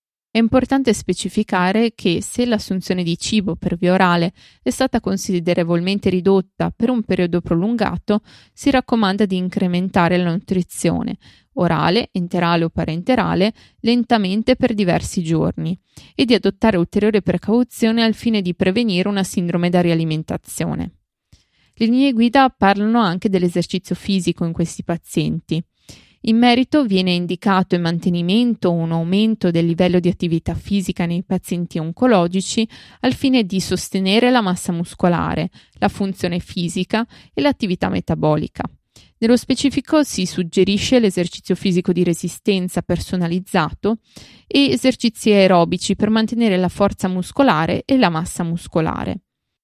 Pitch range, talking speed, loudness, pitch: 180-225 Hz, 130 wpm, -18 LUFS, 190 Hz